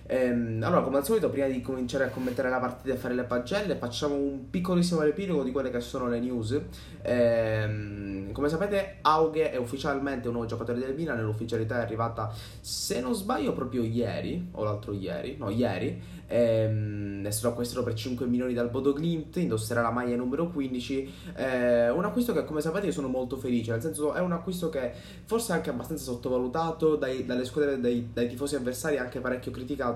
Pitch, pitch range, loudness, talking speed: 125 Hz, 120-150 Hz, -29 LUFS, 190 wpm